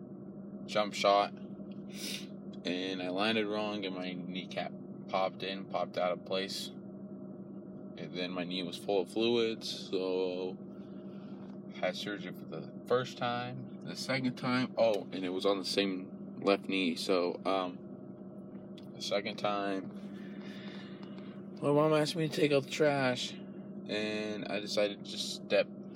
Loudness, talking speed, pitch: -34 LUFS, 150 wpm, 125 Hz